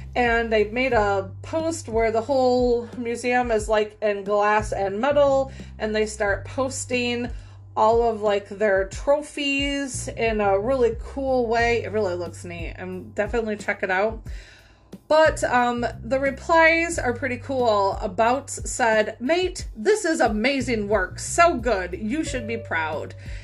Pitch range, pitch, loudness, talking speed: 205-270 Hz, 230 Hz, -22 LUFS, 150 wpm